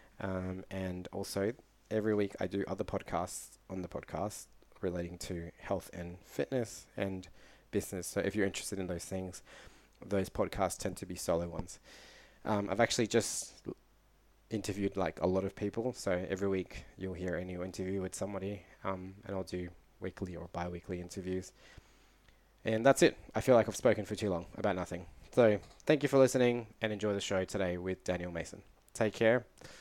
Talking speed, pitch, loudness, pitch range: 180 wpm, 95 Hz, -35 LUFS, 90-105 Hz